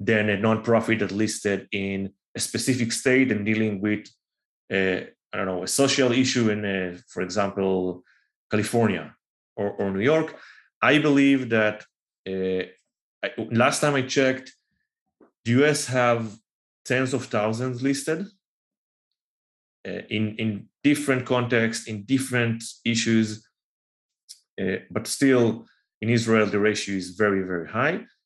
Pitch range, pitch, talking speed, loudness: 100-130 Hz, 110 Hz, 135 wpm, -24 LUFS